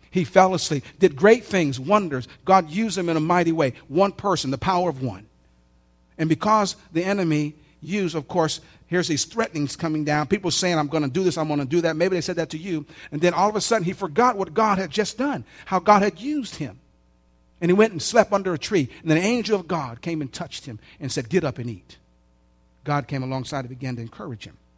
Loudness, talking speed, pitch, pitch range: -22 LUFS, 240 wpm, 165 Hz, 135-190 Hz